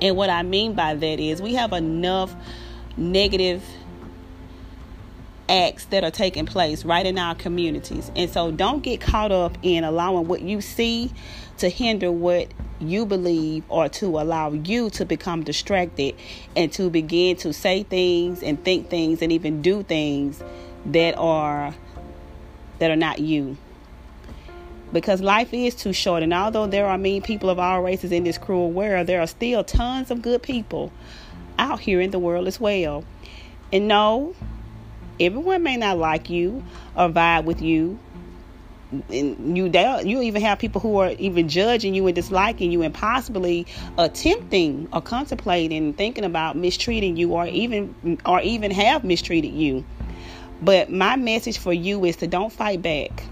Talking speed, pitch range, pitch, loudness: 165 wpm, 155-195 Hz, 175 Hz, -22 LUFS